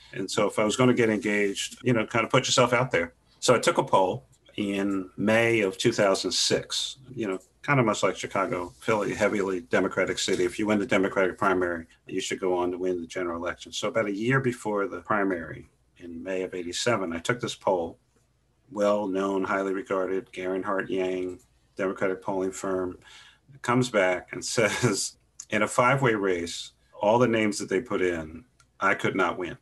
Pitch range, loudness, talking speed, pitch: 90-110 Hz, -26 LUFS, 195 wpm, 95 Hz